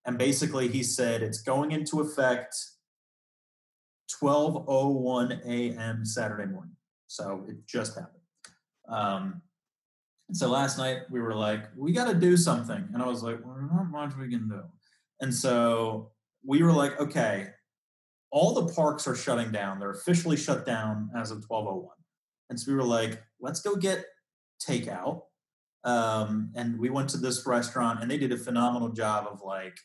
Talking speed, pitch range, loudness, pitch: 165 wpm, 115-150 Hz, -29 LUFS, 125 Hz